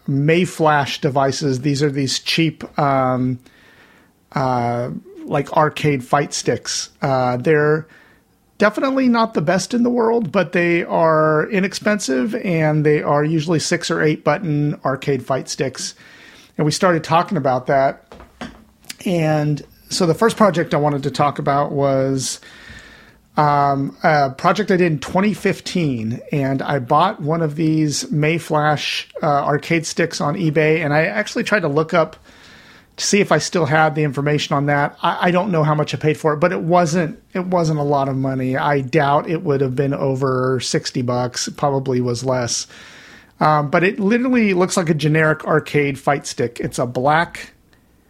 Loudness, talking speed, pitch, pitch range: -18 LUFS, 170 wpm, 155 Hz, 140-175 Hz